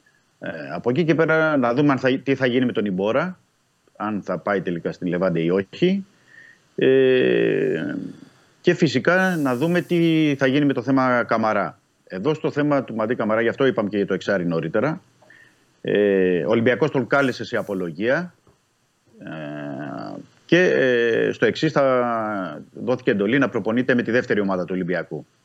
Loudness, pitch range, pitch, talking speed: -21 LUFS, 105-145 Hz, 125 Hz, 170 wpm